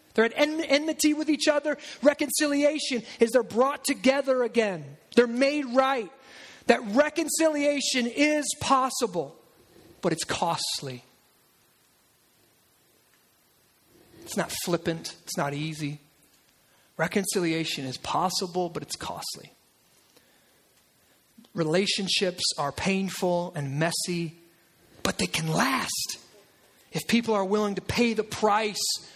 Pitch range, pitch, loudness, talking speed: 170-275 Hz, 215 Hz, -26 LUFS, 105 wpm